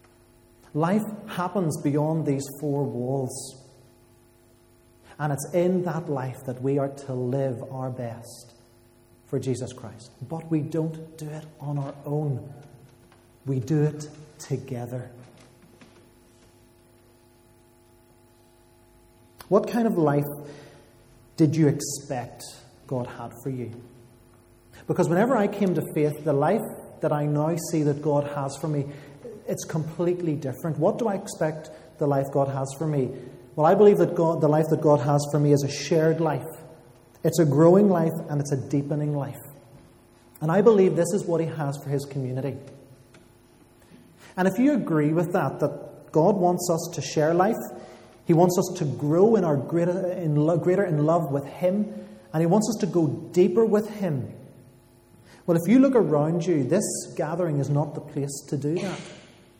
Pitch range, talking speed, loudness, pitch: 125-165 Hz, 165 wpm, -24 LUFS, 145 Hz